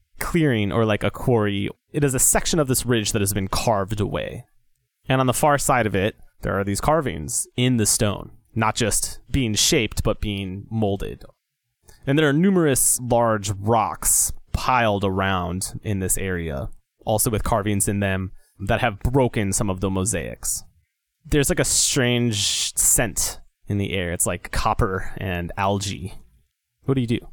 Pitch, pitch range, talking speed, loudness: 110 Hz, 100-125 Hz, 170 wpm, -21 LUFS